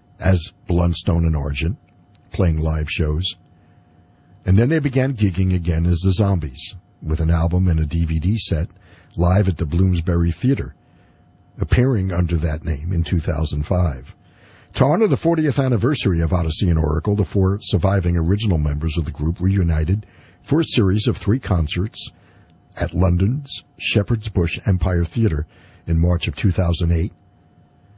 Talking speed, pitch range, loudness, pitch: 145 wpm, 85-100 Hz, -20 LUFS, 90 Hz